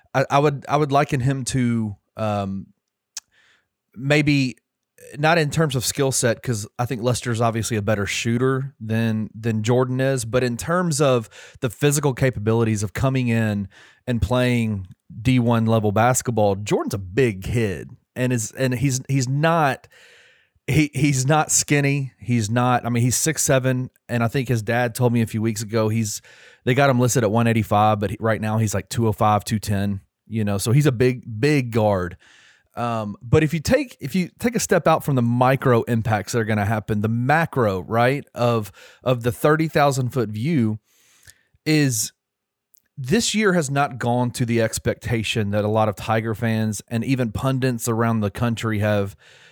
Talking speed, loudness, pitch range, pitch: 180 wpm, -21 LUFS, 110-135 Hz, 120 Hz